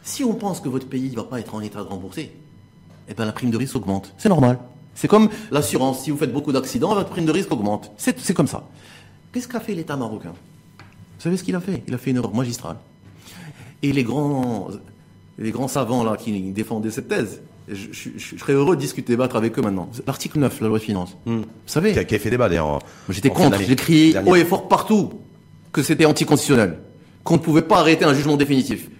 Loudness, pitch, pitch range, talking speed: -20 LUFS, 135 Hz, 110-160 Hz, 235 wpm